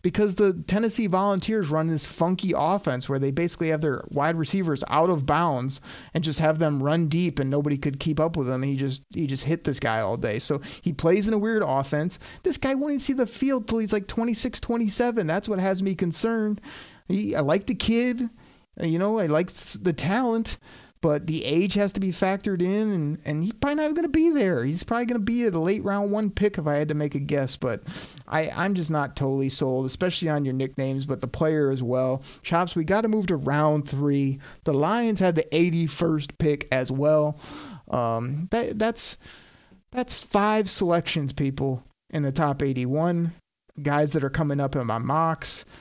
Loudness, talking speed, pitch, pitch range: -25 LUFS, 210 wpm, 165 Hz, 145-205 Hz